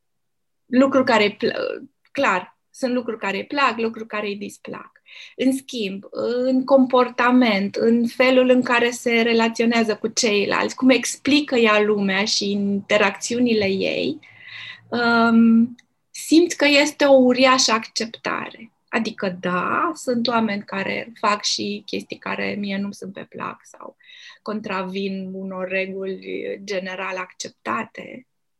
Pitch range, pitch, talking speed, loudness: 200-255 Hz, 230 Hz, 125 wpm, -20 LUFS